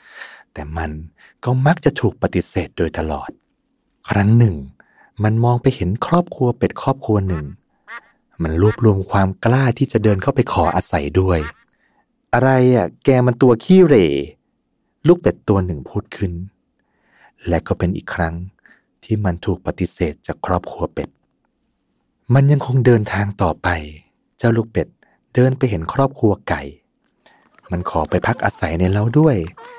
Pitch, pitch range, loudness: 105 Hz, 90-125 Hz, -18 LUFS